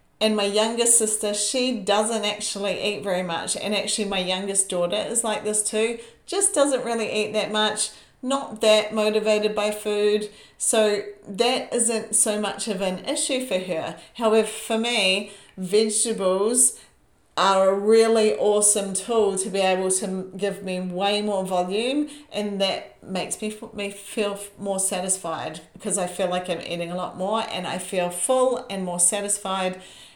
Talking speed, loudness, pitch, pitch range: 160 wpm, -23 LUFS, 210 Hz, 195-220 Hz